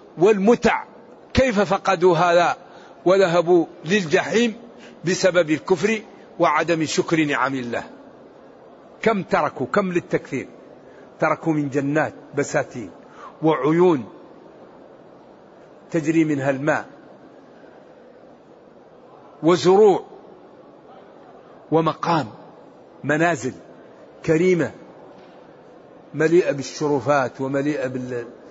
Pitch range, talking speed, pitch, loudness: 145-185 Hz, 65 wpm, 165 Hz, -20 LUFS